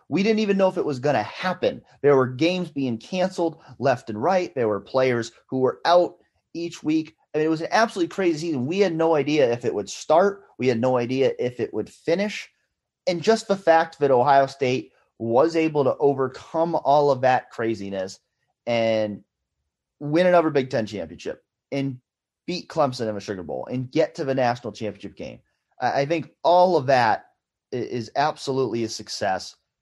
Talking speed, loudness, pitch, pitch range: 190 wpm, -23 LUFS, 140 Hz, 120-165 Hz